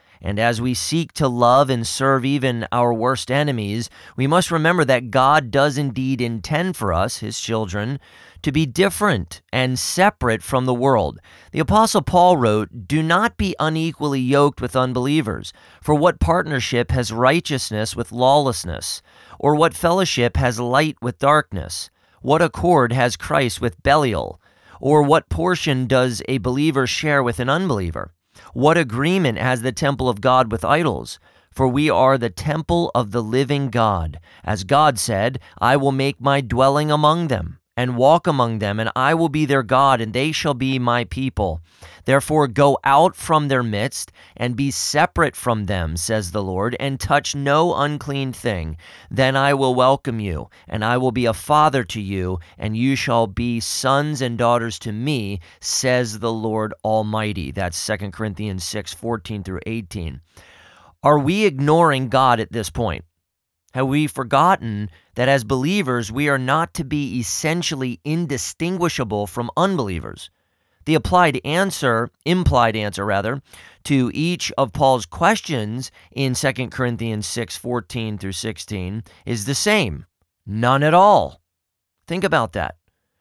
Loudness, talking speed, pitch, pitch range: -19 LUFS, 155 wpm, 125 Hz, 110-145 Hz